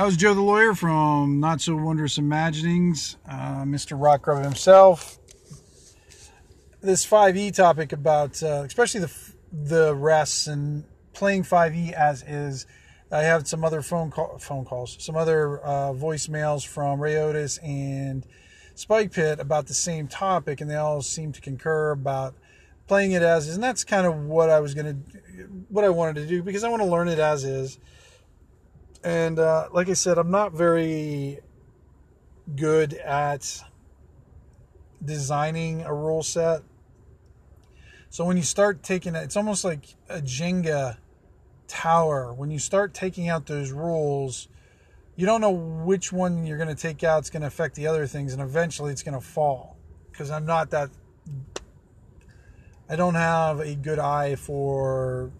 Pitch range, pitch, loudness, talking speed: 140-170 Hz, 150 Hz, -24 LUFS, 160 wpm